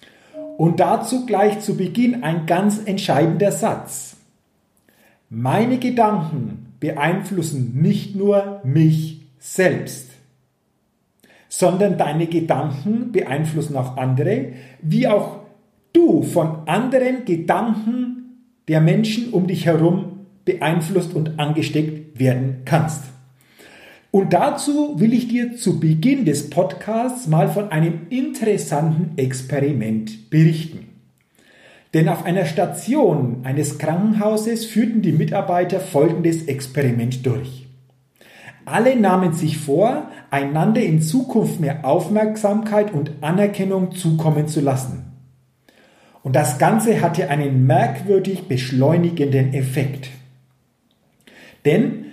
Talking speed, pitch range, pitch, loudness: 100 wpm, 140-205 Hz, 165 Hz, -19 LUFS